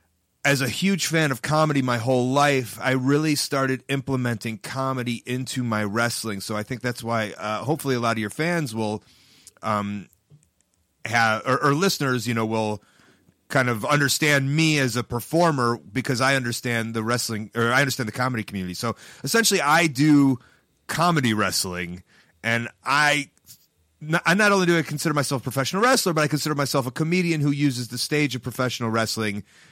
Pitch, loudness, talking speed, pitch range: 130 Hz, -23 LUFS, 180 wpm, 115-145 Hz